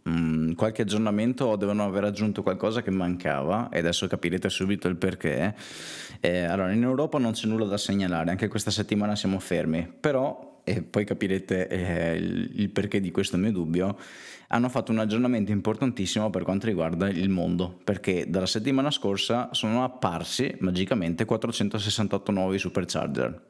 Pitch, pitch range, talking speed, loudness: 100 Hz, 90-110 Hz, 155 wpm, -27 LUFS